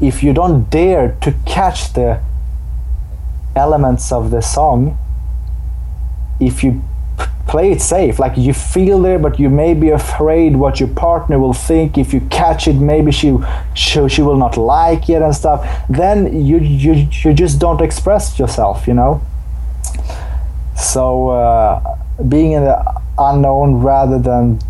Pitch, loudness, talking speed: 135 Hz, -13 LUFS, 155 wpm